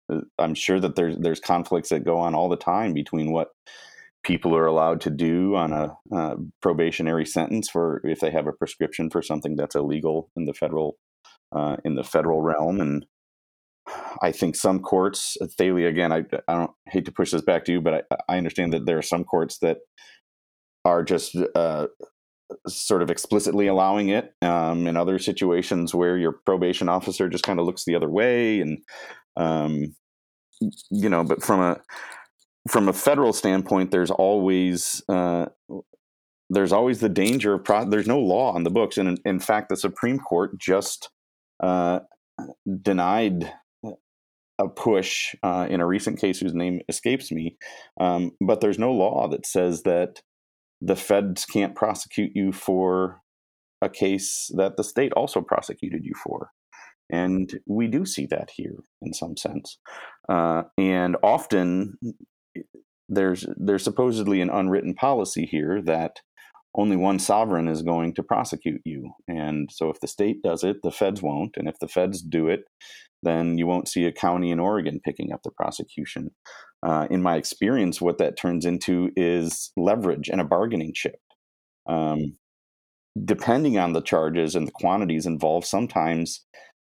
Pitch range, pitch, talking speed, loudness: 80-95 Hz, 90 Hz, 165 wpm, -24 LUFS